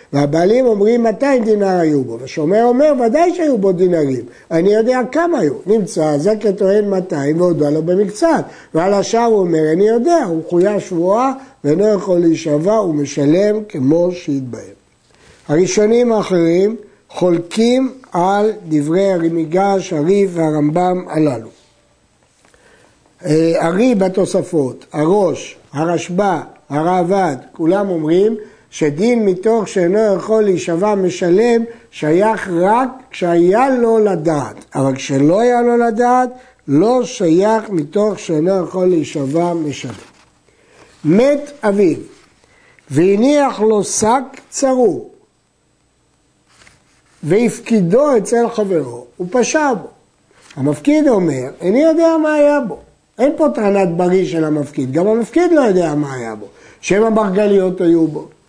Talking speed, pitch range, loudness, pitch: 120 wpm, 165-230 Hz, -14 LUFS, 195 Hz